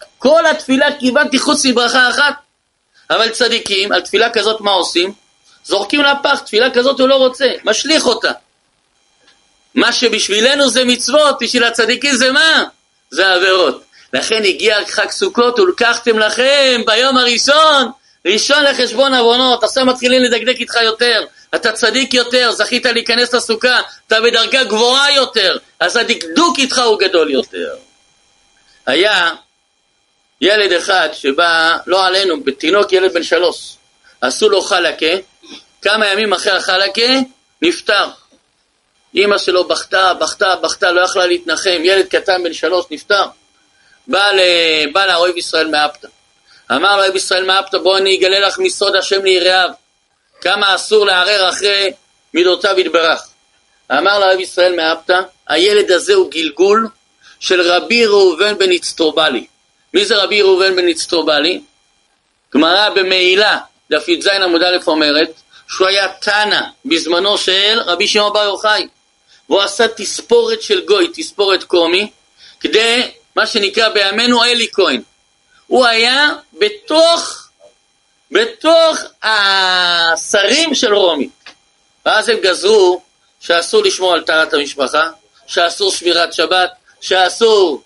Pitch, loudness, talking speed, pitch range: 220 Hz, -12 LUFS, 125 wpm, 185-275 Hz